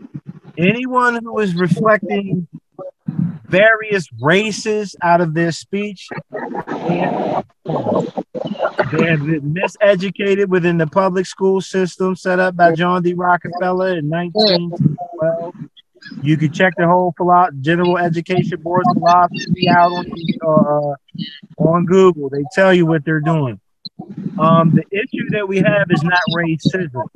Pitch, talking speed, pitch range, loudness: 180 Hz, 125 wpm, 170-190 Hz, -16 LUFS